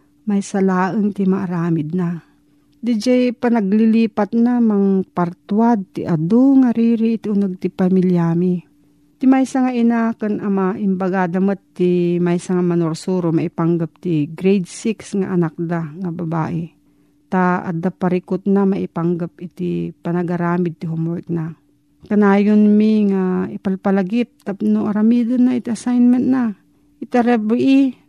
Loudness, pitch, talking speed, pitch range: -18 LUFS, 190 Hz, 130 wpm, 170-220 Hz